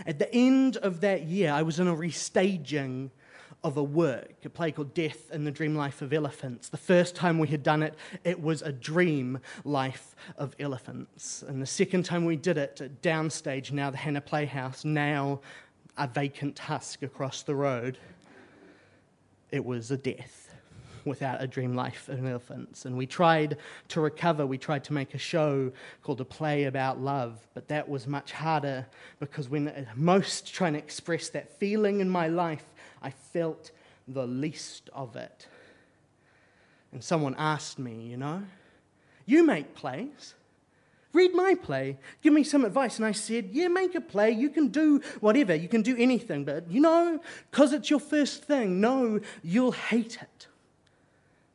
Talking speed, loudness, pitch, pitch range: 170 wpm, -29 LUFS, 155 Hz, 140-190 Hz